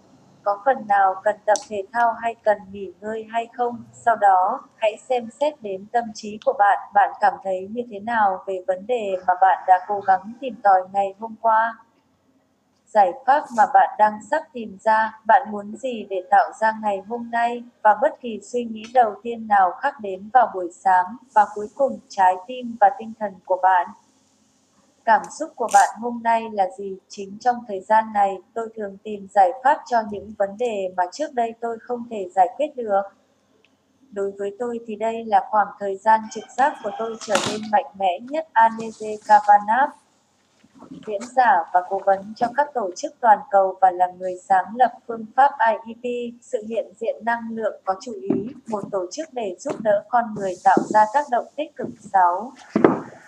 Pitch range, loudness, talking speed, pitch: 200-250 Hz, -21 LUFS, 195 wpm, 225 Hz